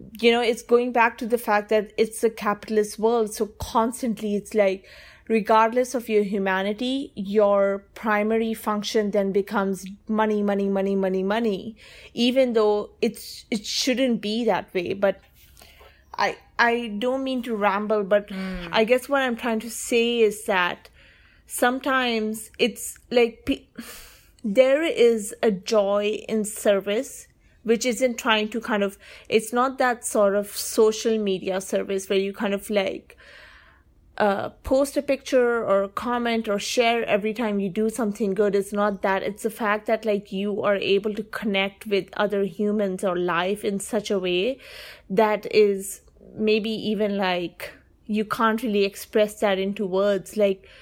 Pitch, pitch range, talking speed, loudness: 215 Hz, 200-230 Hz, 160 wpm, -23 LUFS